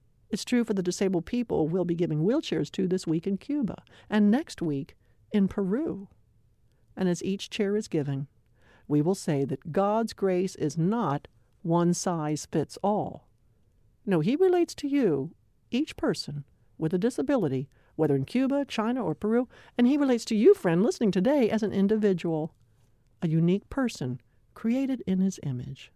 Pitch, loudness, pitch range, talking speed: 180 Hz, -27 LUFS, 140-220 Hz, 165 wpm